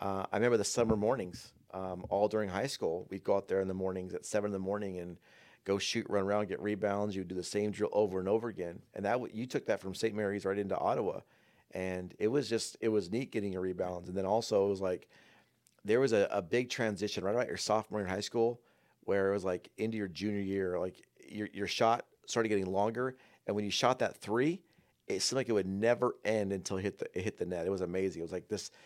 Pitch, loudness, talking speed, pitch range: 100 Hz, -34 LUFS, 255 wpm, 95-110 Hz